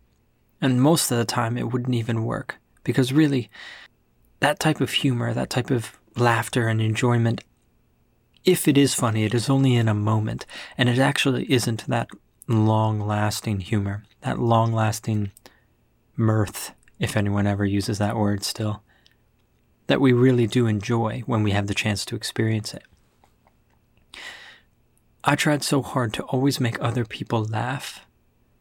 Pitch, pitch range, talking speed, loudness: 115 Hz, 110-130 Hz, 155 wpm, -23 LUFS